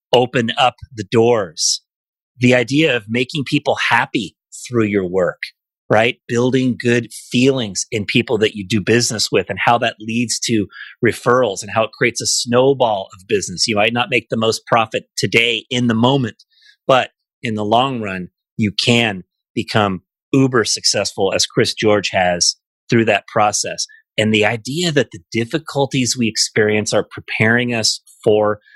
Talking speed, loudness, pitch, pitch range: 165 wpm, -16 LUFS, 115 Hz, 105-130 Hz